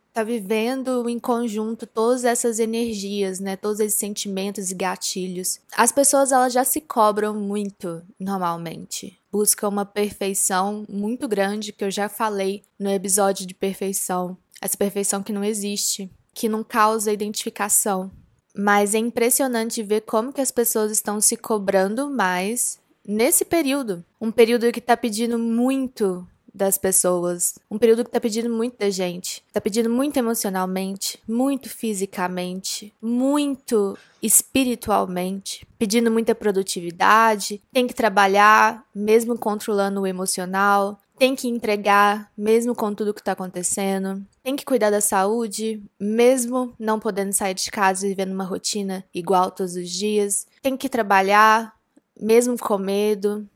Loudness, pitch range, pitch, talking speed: -21 LUFS, 195-235 Hz, 210 Hz, 140 wpm